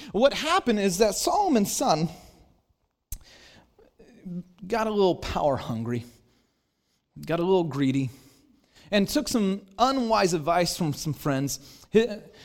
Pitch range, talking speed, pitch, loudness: 140-225 Hz, 110 wpm, 190 Hz, -25 LUFS